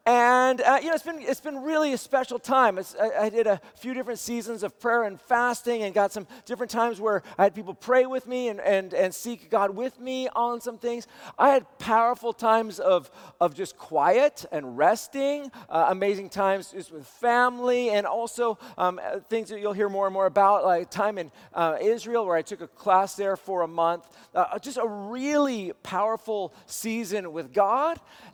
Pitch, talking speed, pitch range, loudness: 225 Hz, 200 wpm, 195-245 Hz, -25 LUFS